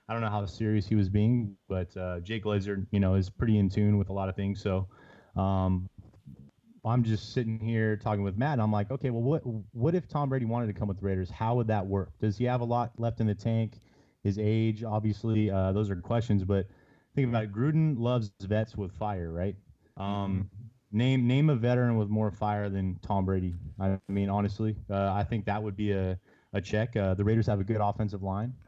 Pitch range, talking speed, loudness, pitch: 100-115 Hz, 225 wpm, -30 LUFS, 105 Hz